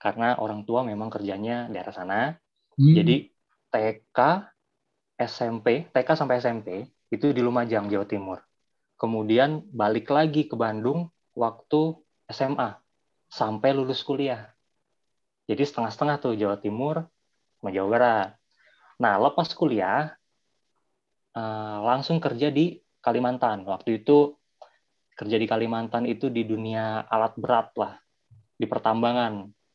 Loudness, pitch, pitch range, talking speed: -25 LUFS, 120 Hz, 110-140 Hz, 115 wpm